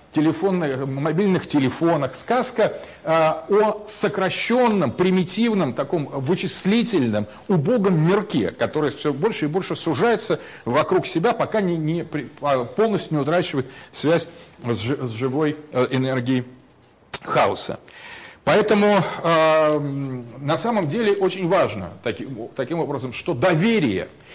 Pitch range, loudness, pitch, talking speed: 145-200 Hz, -21 LUFS, 165 Hz, 115 wpm